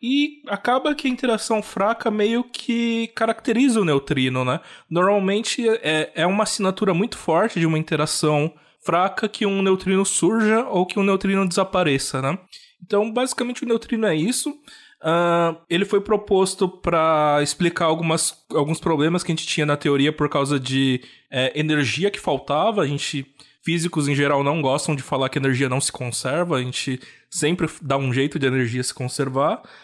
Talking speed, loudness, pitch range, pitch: 175 wpm, -21 LUFS, 145-210 Hz, 170 Hz